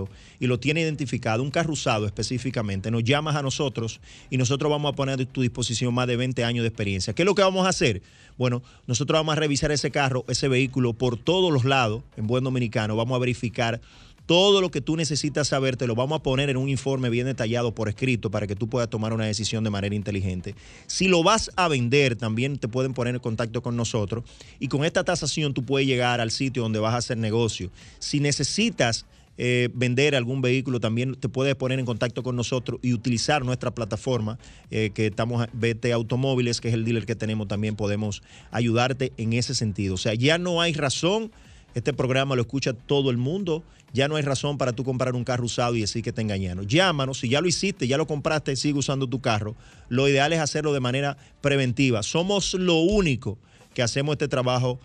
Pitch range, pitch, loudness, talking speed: 115-140 Hz, 125 Hz, -24 LUFS, 215 wpm